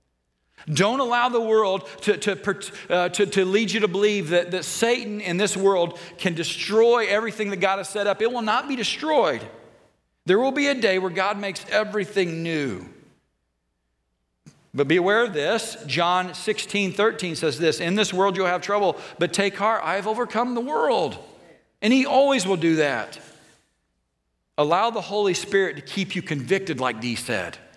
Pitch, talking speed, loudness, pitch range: 195 Hz, 175 wpm, -23 LUFS, 170-215 Hz